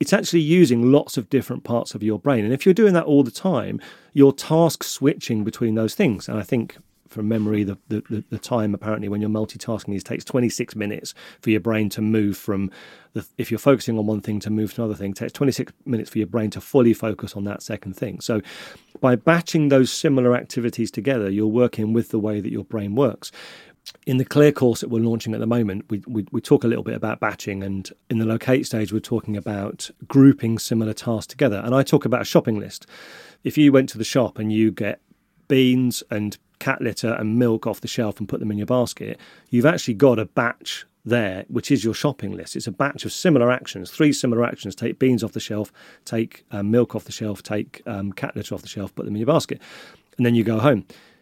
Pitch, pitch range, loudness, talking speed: 115 Hz, 105-130 Hz, -21 LUFS, 235 wpm